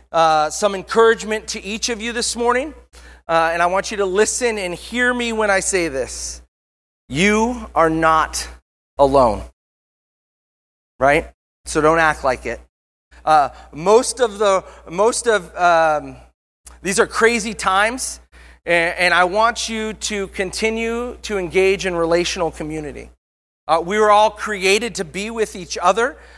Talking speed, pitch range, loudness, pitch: 150 wpm, 155-220 Hz, -18 LUFS, 190 Hz